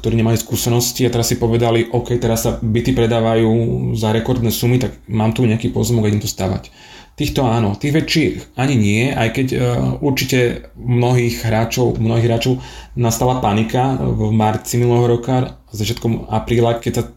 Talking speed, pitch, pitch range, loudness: 160 wpm, 115 Hz, 115-125 Hz, -17 LUFS